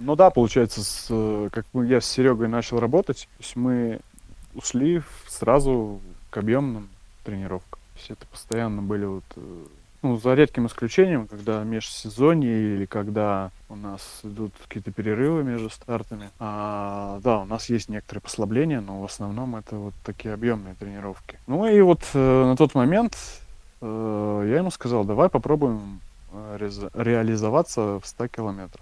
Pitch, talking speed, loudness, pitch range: 110 Hz, 145 wpm, -23 LUFS, 105-125 Hz